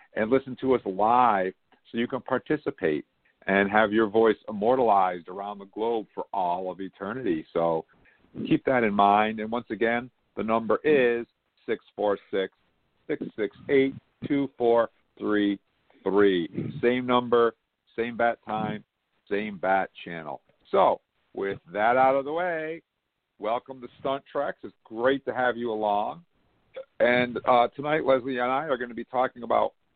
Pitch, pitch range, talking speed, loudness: 115 Hz, 105-130 Hz, 145 wpm, -26 LUFS